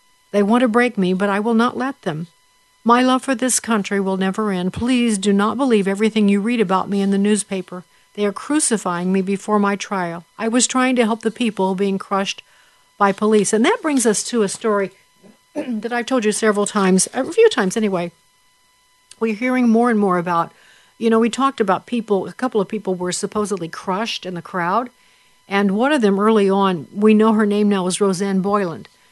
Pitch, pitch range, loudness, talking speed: 210 Hz, 195-240 Hz, -18 LUFS, 210 wpm